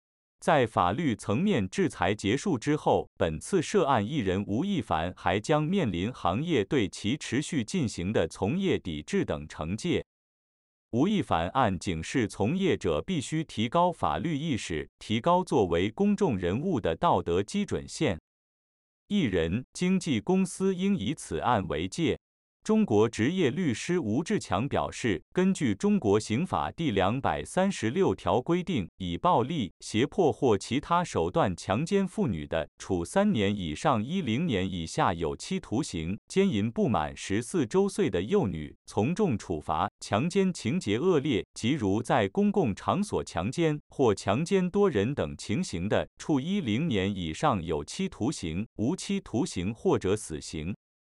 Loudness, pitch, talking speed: -28 LUFS, 150 Hz, 230 characters per minute